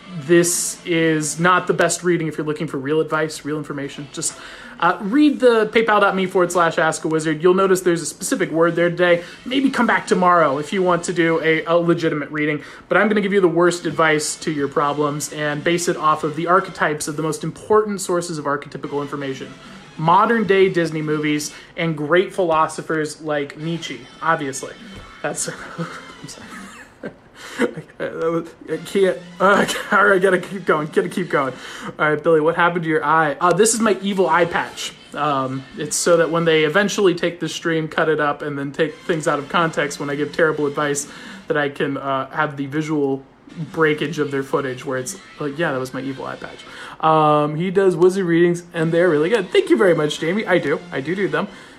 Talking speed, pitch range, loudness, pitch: 205 wpm, 150-180 Hz, -19 LUFS, 165 Hz